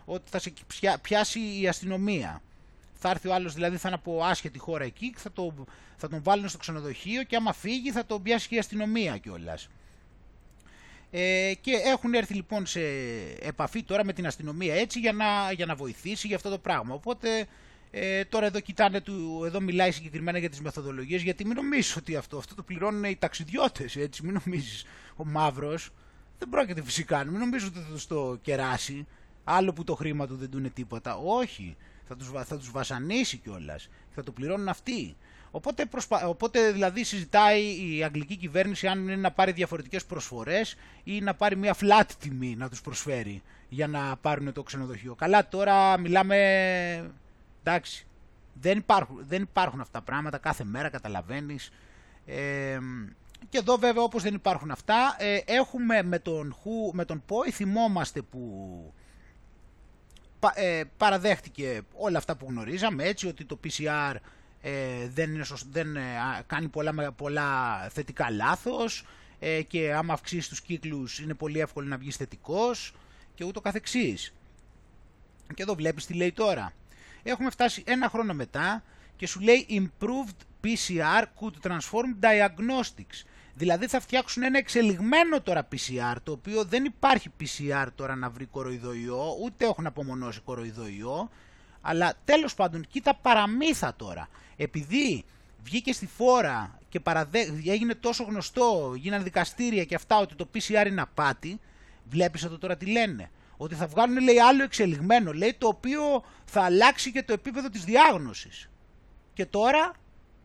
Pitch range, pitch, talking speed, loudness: 145-215 Hz, 180 Hz, 160 wpm, -28 LUFS